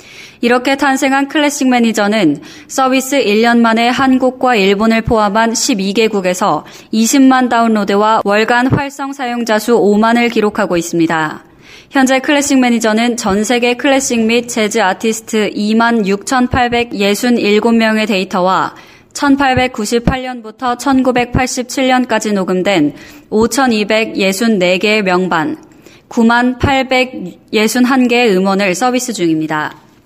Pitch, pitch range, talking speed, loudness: 235 Hz, 210-255 Hz, 220 characters per minute, -12 LUFS